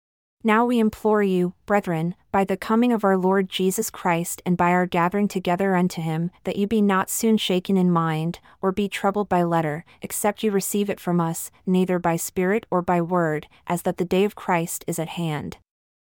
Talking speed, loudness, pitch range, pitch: 200 wpm, -23 LUFS, 170-200 Hz, 185 Hz